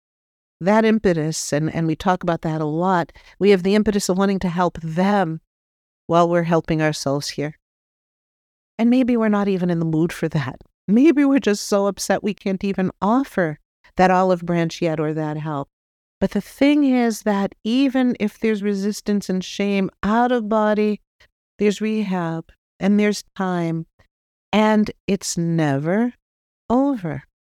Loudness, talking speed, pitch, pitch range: -20 LUFS, 160 wpm, 190 Hz, 165-210 Hz